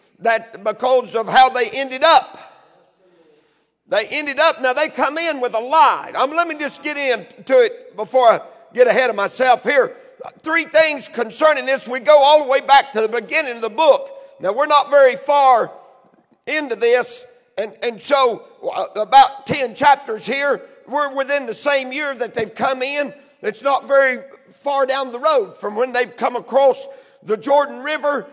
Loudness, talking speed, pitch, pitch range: -17 LUFS, 180 wpm, 270 Hz, 245-300 Hz